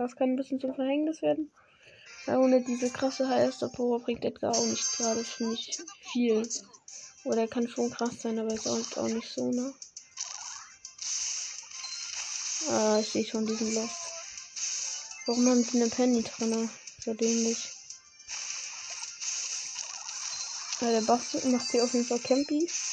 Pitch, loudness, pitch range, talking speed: 240 Hz, -30 LUFS, 225-260 Hz, 150 wpm